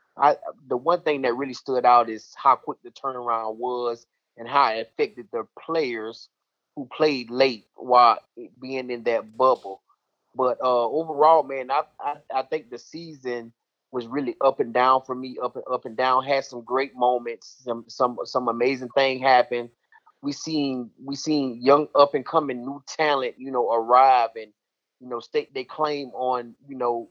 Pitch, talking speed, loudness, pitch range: 130 Hz, 185 wpm, -23 LUFS, 120-145 Hz